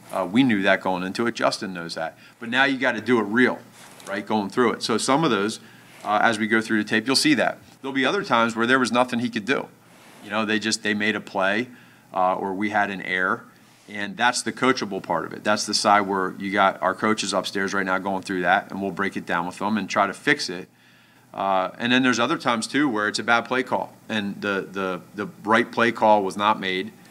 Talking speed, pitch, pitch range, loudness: 260 wpm, 105 Hz, 100-120 Hz, -22 LUFS